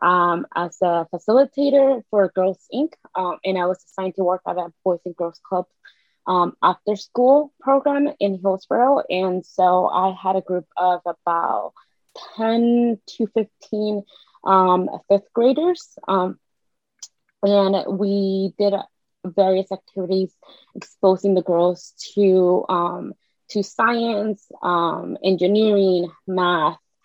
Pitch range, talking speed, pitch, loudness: 180-215 Hz, 125 wpm, 190 Hz, -20 LUFS